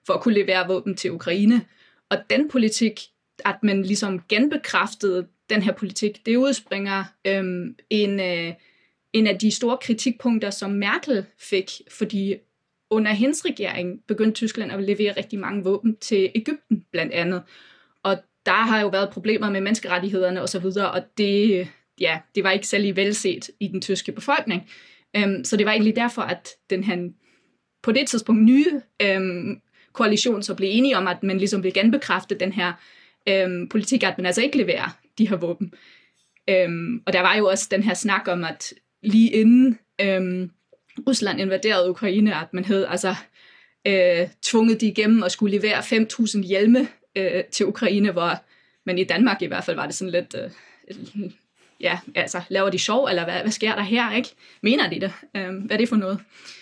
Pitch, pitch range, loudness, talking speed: 200 Hz, 190-225 Hz, -22 LUFS, 180 wpm